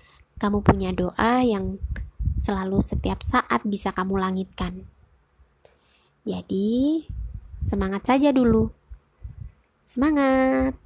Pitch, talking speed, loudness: 190 Hz, 85 wpm, -23 LUFS